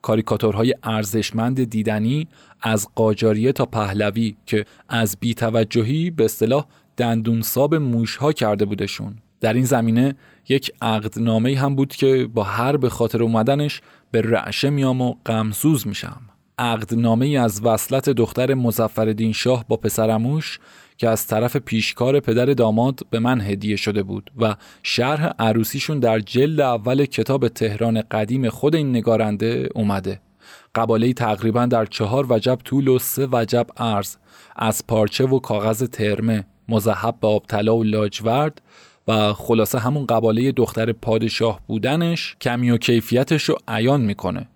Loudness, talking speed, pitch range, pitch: -20 LUFS, 135 wpm, 110-130 Hz, 115 Hz